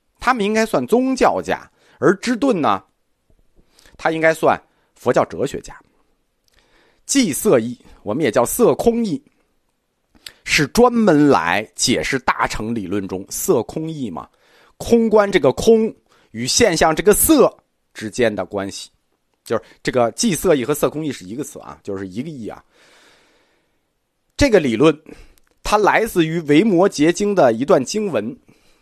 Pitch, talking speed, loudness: 175 Hz, 210 characters per minute, -17 LUFS